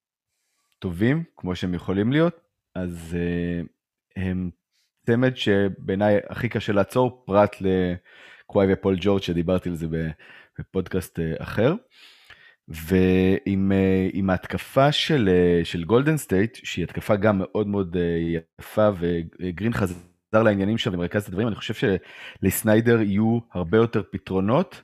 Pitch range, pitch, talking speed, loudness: 90-110 Hz, 95 Hz, 120 wpm, -23 LUFS